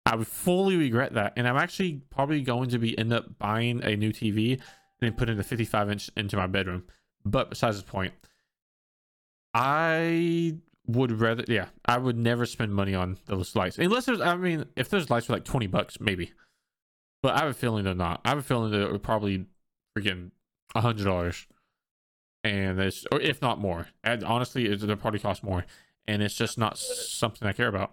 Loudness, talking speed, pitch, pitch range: -28 LUFS, 205 wpm, 115 Hz, 100-125 Hz